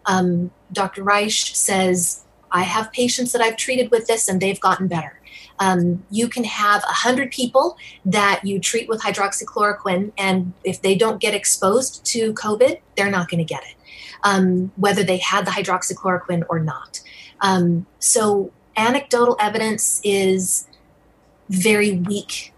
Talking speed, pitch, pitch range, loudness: 150 wpm, 200 Hz, 185-225 Hz, -19 LUFS